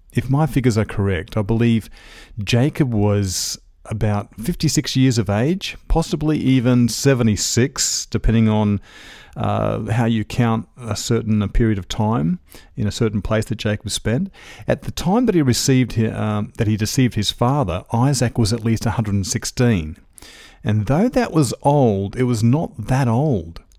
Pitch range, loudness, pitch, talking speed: 105-130 Hz, -19 LUFS, 115 Hz, 160 wpm